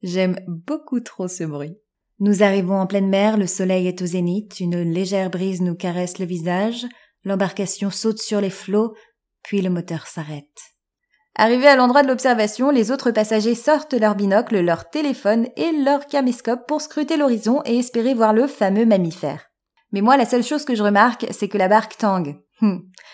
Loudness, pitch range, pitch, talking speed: -19 LUFS, 185-245 Hz, 210 Hz, 180 wpm